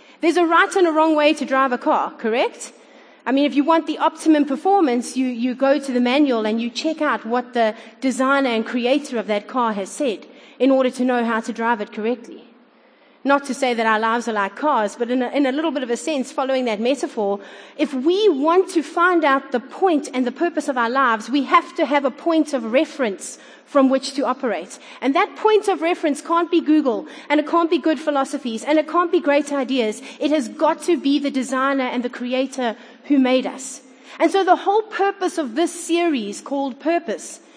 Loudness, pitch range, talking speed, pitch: -20 LUFS, 245-315 Hz, 225 wpm, 275 Hz